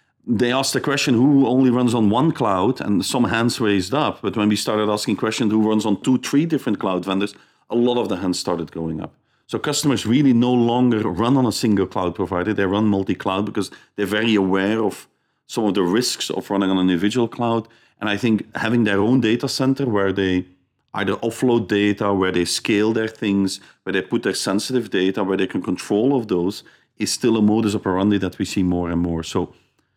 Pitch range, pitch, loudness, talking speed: 95-120 Hz, 105 Hz, -20 LUFS, 215 wpm